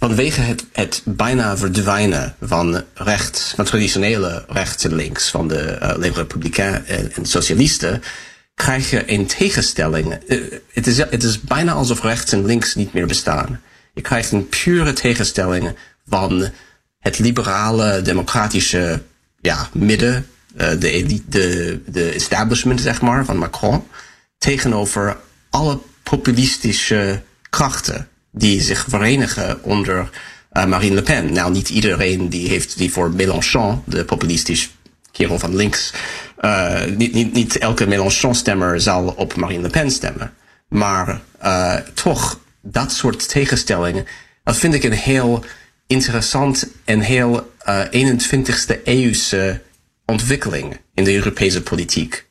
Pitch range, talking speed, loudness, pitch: 95-125 Hz, 130 wpm, -17 LUFS, 105 Hz